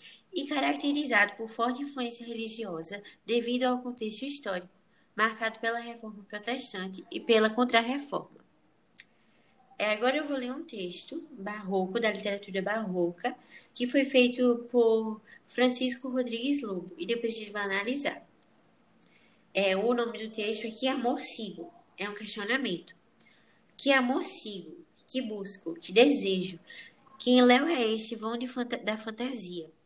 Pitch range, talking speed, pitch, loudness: 205-255 Hz, 140 wpm, 230 Hz, -30 LUFS